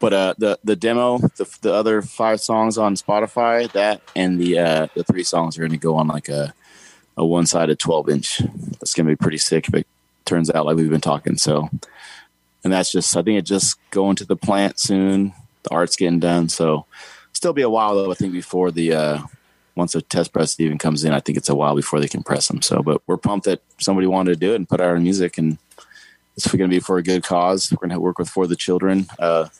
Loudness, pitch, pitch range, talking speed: -19 LUFS, 90 Hz, 80-95 Hz, 240 wpm